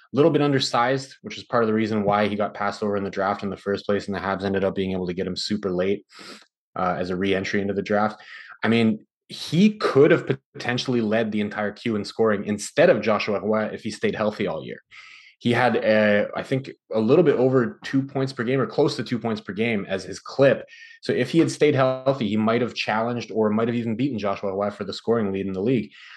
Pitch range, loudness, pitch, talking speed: 100-125 Hz, -23 LUFS, 110 Hz, 250 wpm